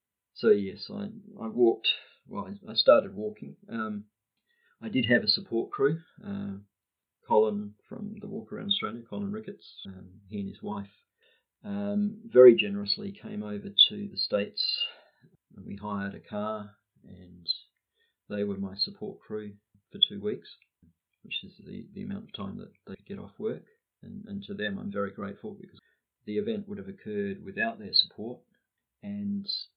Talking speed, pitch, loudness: 165 wpm, 200 Hz, -29 LUFS